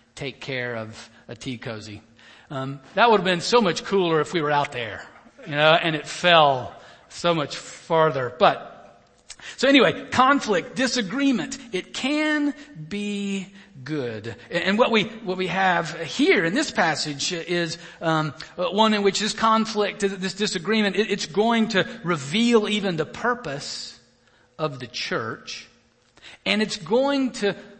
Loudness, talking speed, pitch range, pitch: -22 LUFS, 150 wpm, 150-215 Hz, 185 Hz